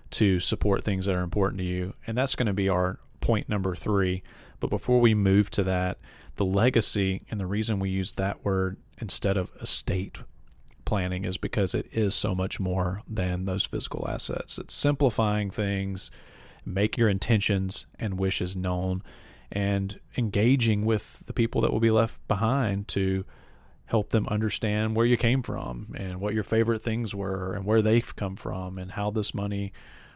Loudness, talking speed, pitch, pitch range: -27 LUFS, 175 wpm, 100 Hz, 95-110 Hz